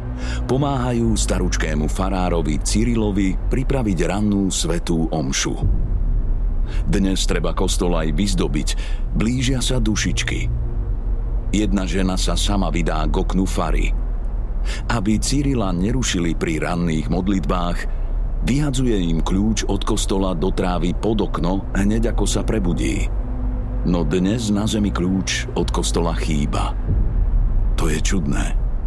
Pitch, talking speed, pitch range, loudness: 100 Hz, 110 wpm, 85-110 Hz, -21 LUFS